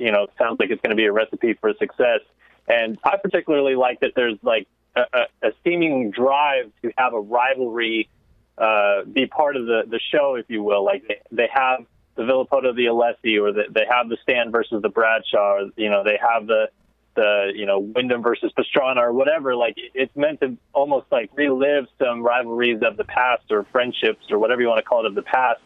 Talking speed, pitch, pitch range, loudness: 220 wpm, 125 Hz, 110-165 Hz, -20 LUFS